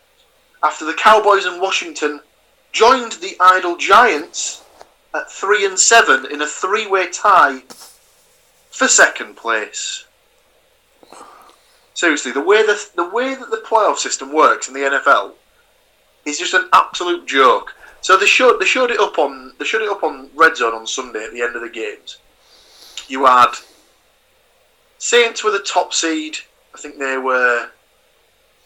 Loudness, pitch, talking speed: -15 LUFS, 215 Hz, 155 wpm